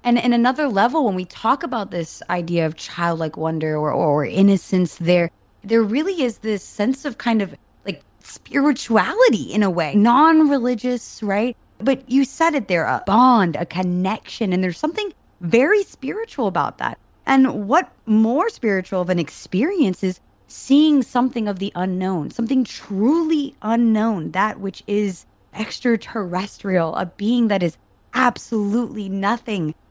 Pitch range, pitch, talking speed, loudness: 180-250 Hz, 215 Hz, 150 wpm, -20 LUFS